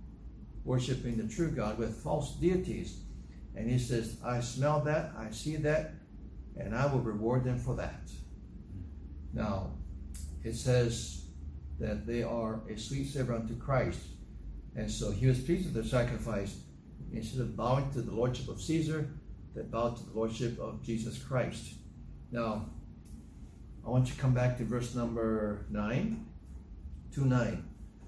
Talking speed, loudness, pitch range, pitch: 150 wpm, -34 LUFS, 85-125 Hz, 115 Hz